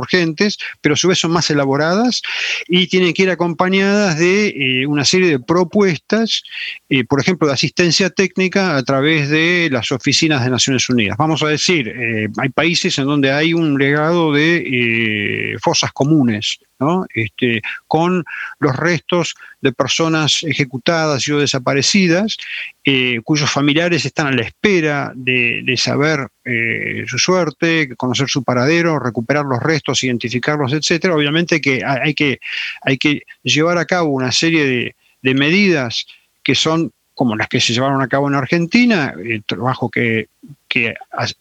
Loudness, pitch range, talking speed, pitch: -15 LUFS, 130-175 Hz, 160 wpm, 150 Hz